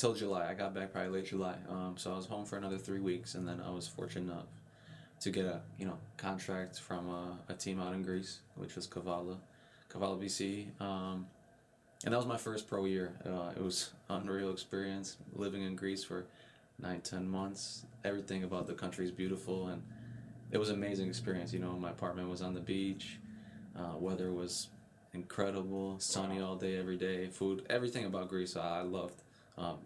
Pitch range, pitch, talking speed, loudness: 90-100 Hz, 95 Hz, 195 wpm, -40 LUFS